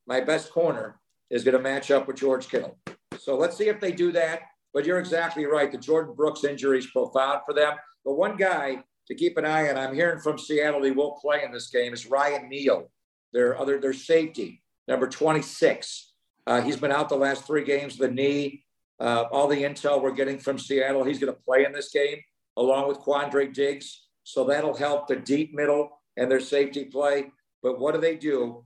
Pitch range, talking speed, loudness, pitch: 135-150 Hz, 210 wpm, -25 LUFS, 140 Hz